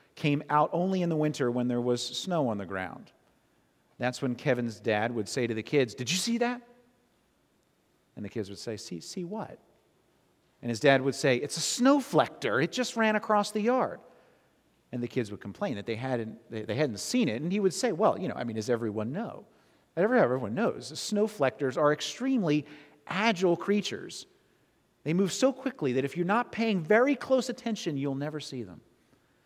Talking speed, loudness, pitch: 195 wpm, -29 LUFS, 150 Hz